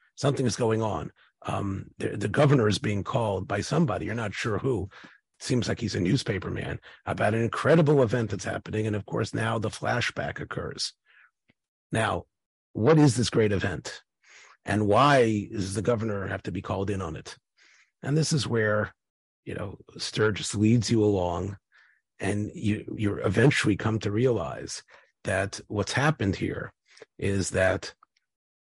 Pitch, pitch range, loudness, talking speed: 105 Hz, 100-115 Hz, -27 LUFS, 165 wpm